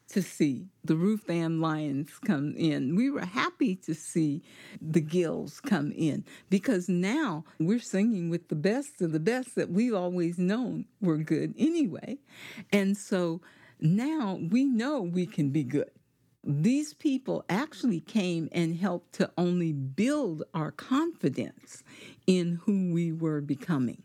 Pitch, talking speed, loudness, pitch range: 180 Hz, 145 wpm, -29 LUFS, 165-225 Hz